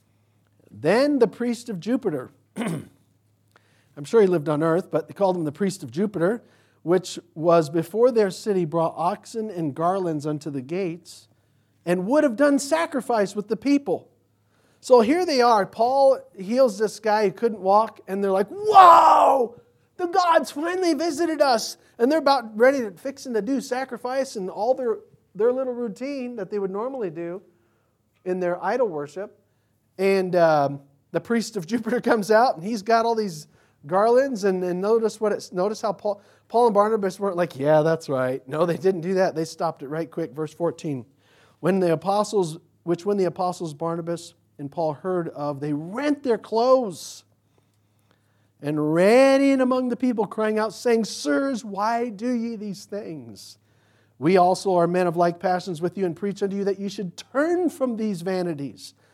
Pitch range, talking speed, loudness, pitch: 160-235 Hz, 180 wpm, -22 LUFS, 190 Hz